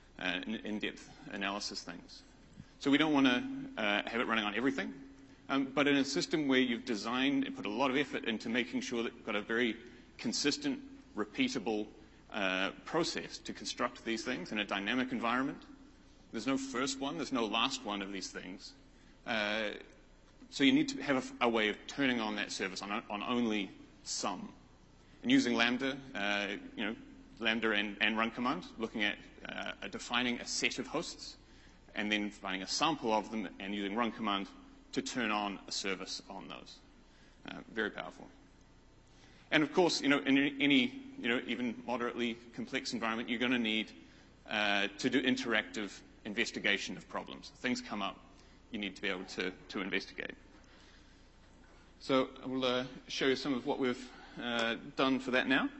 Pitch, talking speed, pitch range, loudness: 120 Hz, 185 wpm, 105-135 Hz, -34 LUFS